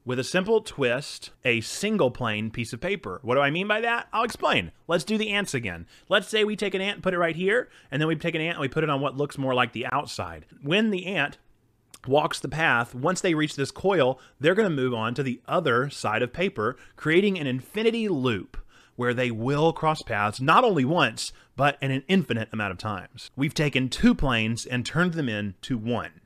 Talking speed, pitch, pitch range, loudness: 230 wpm, 140 Hz, 120-180 Hz, -25 LUFS